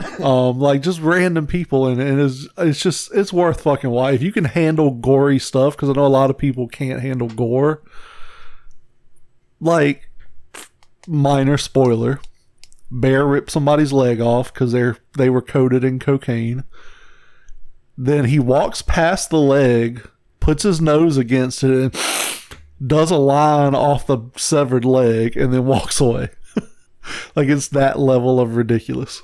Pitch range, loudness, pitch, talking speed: 125-150 Hz, -17 LUFS, 135 Hz, 155 wpm